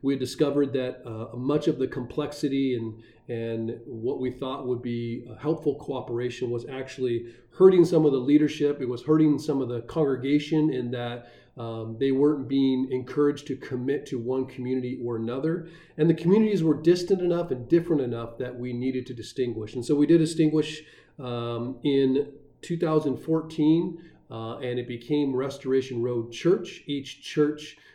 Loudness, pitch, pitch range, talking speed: -26 LUFS, 135 Hz, 125-150 Hz, 165 wpm